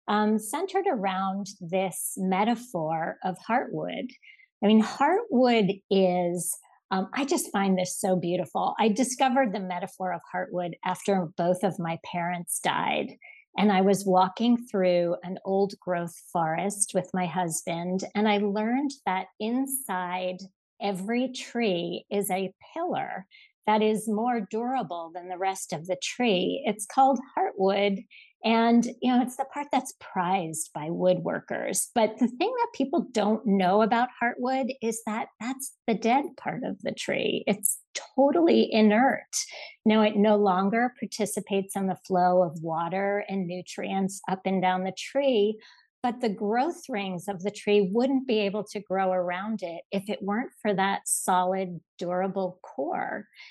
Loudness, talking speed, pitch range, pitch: -27 LUFS, 150 wpm, 185-235 Hz, 200 Hz